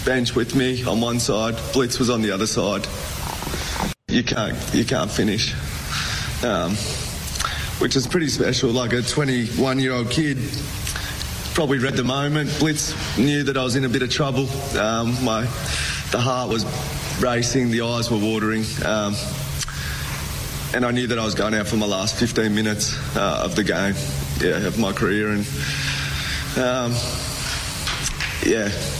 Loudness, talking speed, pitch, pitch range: -22 LUFS, 155 wpm, 120 Hz, 110-130 Hz